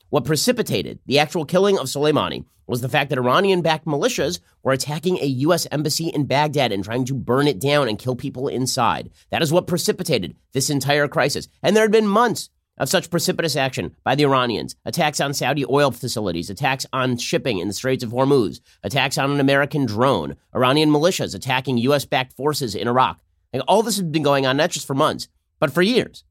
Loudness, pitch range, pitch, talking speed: -20 LUFS, 130-155 Hz, 140 Hz, 205 wpm